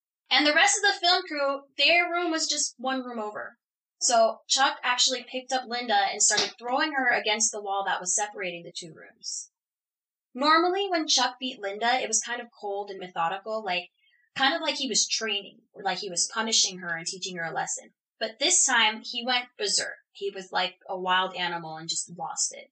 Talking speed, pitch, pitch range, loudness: 210 wpm, 240 Hz, 200-285 Hz, -25 LUFS